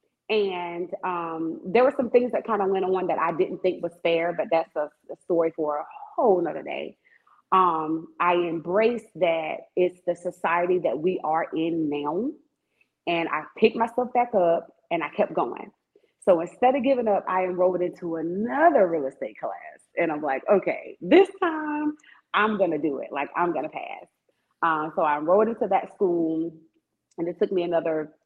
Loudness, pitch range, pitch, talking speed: -25 LUFS, 165-225 Hz, 180 Hz, 190 wpm